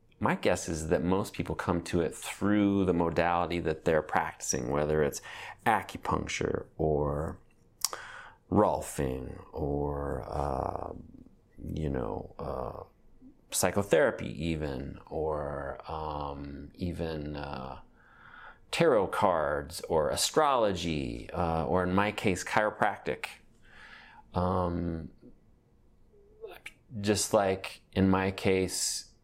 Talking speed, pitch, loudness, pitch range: 95 wpm, 85 Hz, -31 LUFS, 75-95 Hz